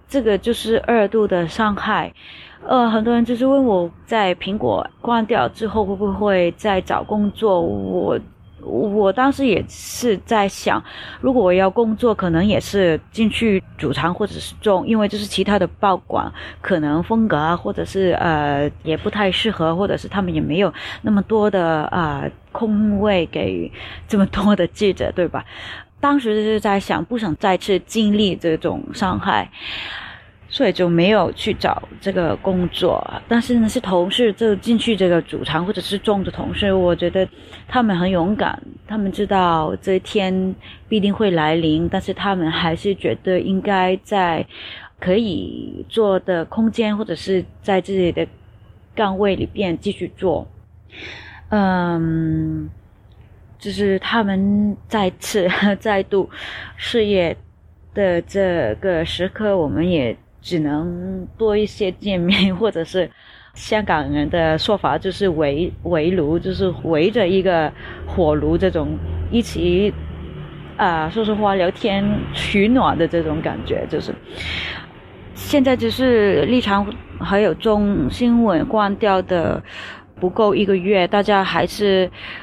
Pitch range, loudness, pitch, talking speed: 170-210 Hz, -19 LUFS, 195 Hz, 215 characters per minute